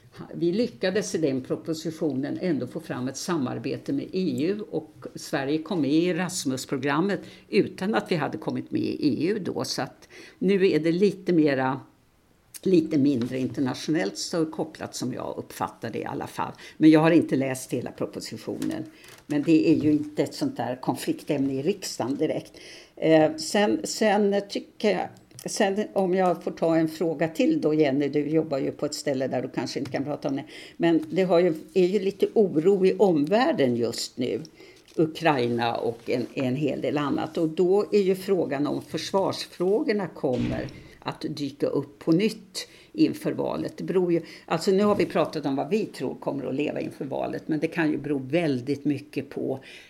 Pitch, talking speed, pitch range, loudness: 160 Hz, 185 wpm, 145-190 Hz, -26 LUFS